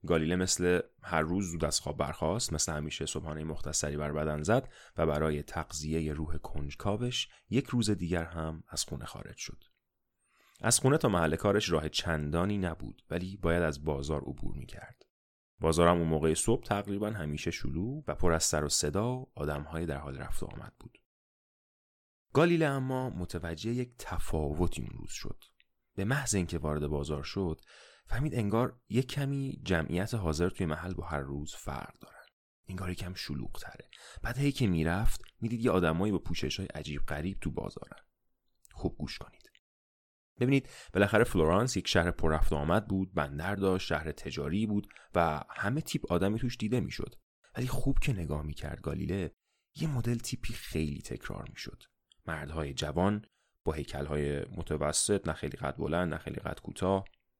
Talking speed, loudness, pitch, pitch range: 165 wpm, -33 LUFS, 85 Hz, 75-110 Hz